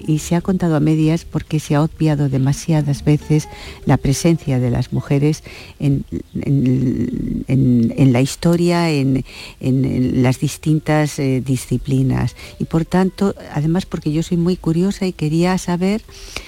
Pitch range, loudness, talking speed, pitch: 130-170 Hz, -18 LUFS, 155 wpm, 150 Hz